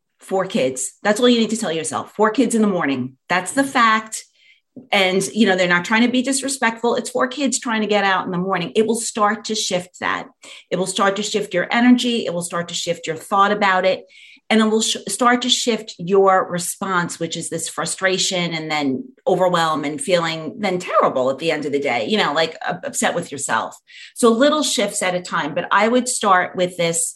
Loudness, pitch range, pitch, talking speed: -19 LUFS, 175-225 Hz, 195 Hz, 230 wpm